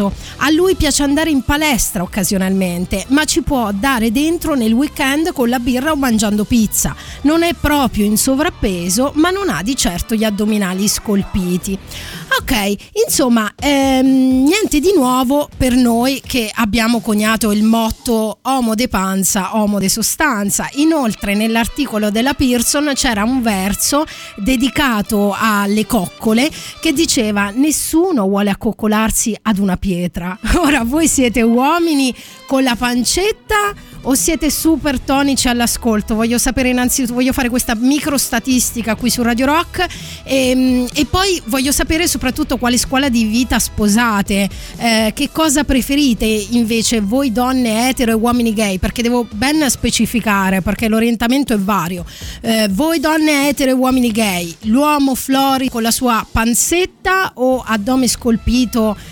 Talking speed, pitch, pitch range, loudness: 140 wpm, 245 Hz, 220-280 Hz, -15 LUFS